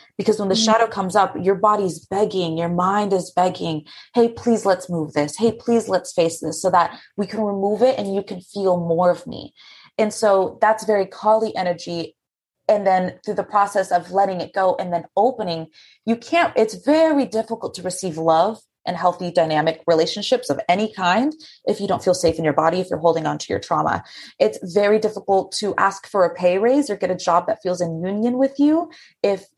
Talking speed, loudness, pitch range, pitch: 210 wpm, -20 LUFS, 175-220 Hz, 195 Hz